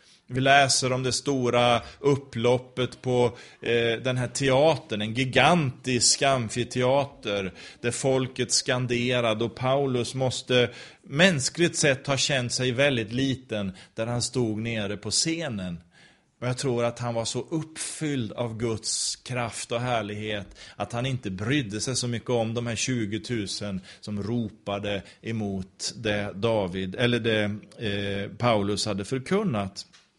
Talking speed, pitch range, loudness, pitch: 135 wpm, 105-130 Hz, -26 LUFS, 120 Hz